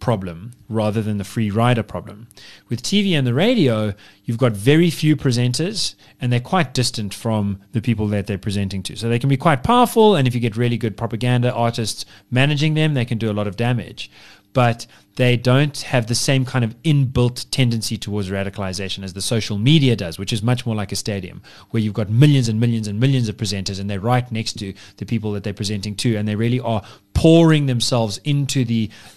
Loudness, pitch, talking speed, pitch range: -19 LUFS, 115 Hz, 215 wpm, 105-130 Hz